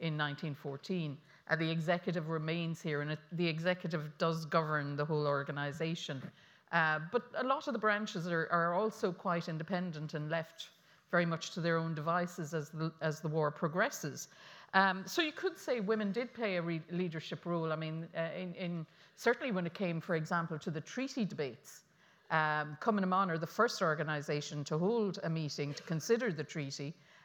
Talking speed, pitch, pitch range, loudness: 185 wpm, 165 Hz, 155-185 Hz, -36 LUFS